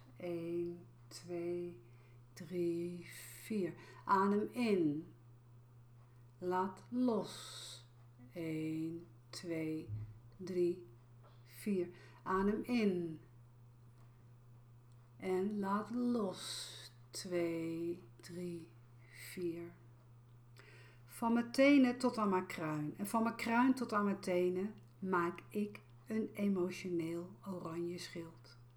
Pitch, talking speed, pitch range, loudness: 170 Hz, 85 wpm, 120-185 Hz, -38 LUFS